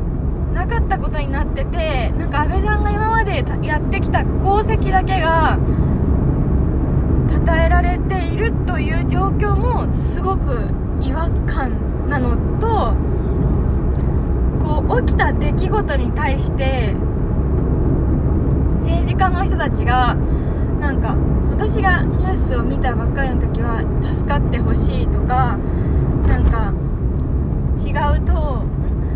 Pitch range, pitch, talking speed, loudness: 65-75 Hz, 70 Hz, 230 characters per minute, -18 LUFS